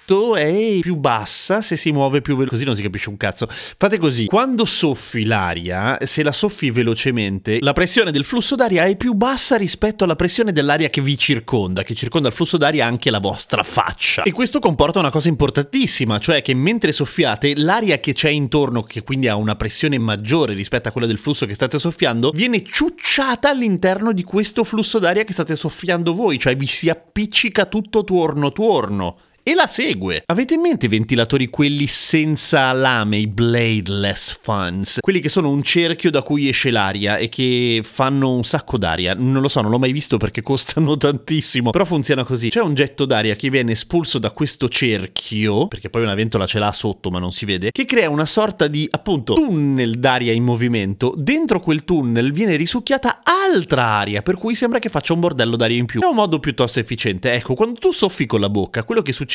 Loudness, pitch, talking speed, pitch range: -17 LUFS, 140 Hz, 200 wpm, 115-180 Hz